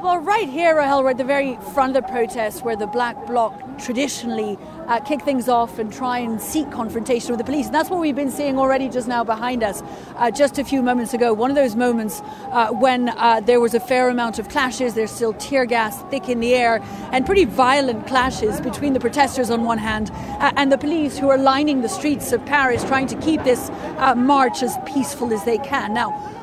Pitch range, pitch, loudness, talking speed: 235-275 Hz, 255 Hz, -19 LUFS, 230 wpm